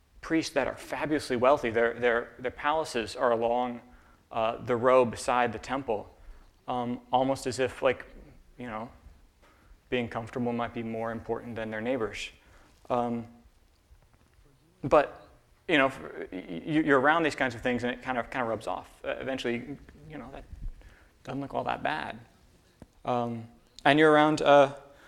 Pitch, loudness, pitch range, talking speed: 120 Hz, -28 LUFS, 115-130 Hz, 160 wpm